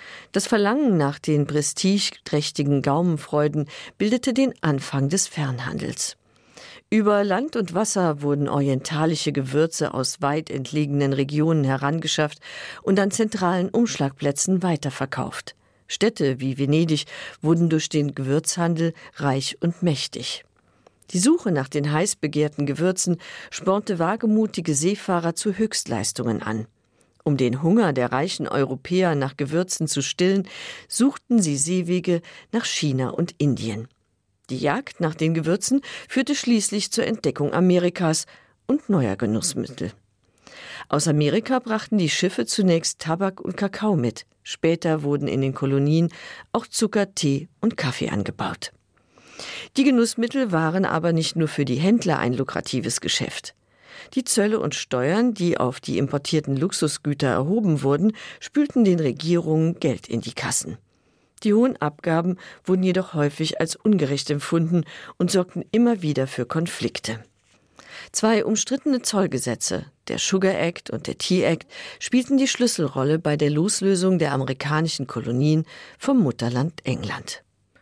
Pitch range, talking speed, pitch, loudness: 140-195 Hz, 130 wpm, 160 Hz, -23 LUFS